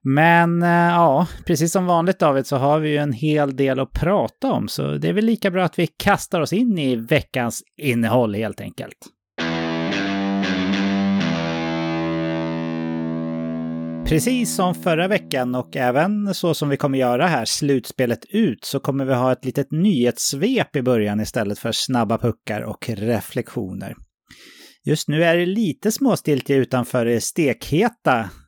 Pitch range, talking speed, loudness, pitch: 105-165 Hz, 150 wpm, -20 LUFS, 130 Hz